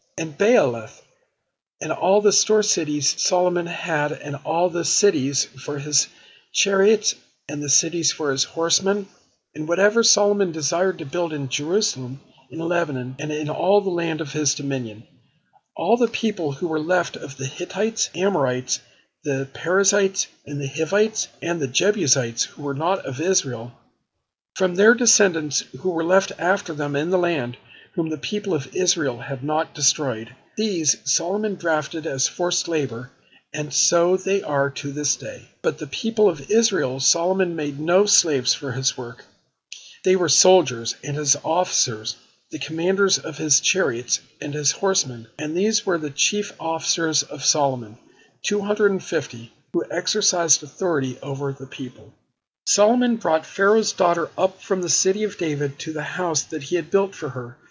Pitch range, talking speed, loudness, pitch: 140-190 Hz, 165 wpm, -21 LUFS, 160 Hz